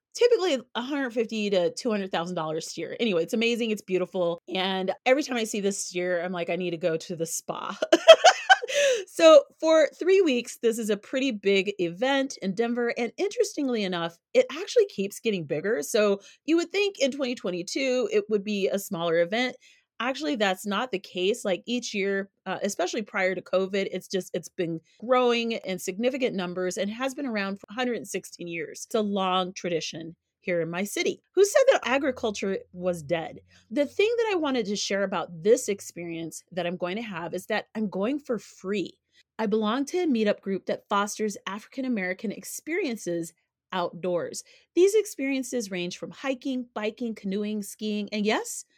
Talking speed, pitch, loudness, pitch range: 180 wpm, 215 Hz, -26 LUFS, 185-265 Hz